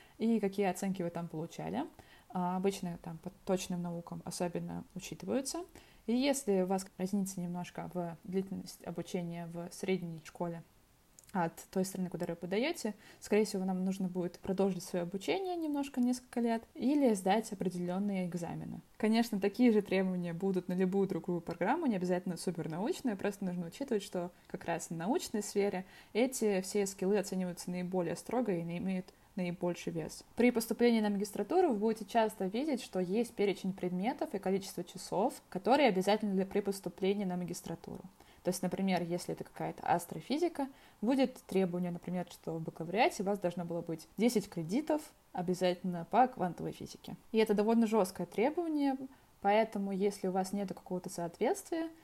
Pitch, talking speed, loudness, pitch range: 190 Hz, 160 wpm, -35 LUFS, 180-220 Hz